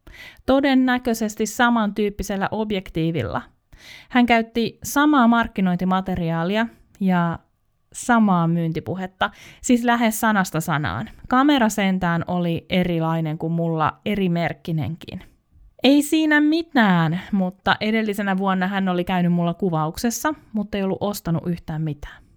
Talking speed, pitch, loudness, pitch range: 105 wpm, 190 Hz, -21 LUFS, 165-225 Hz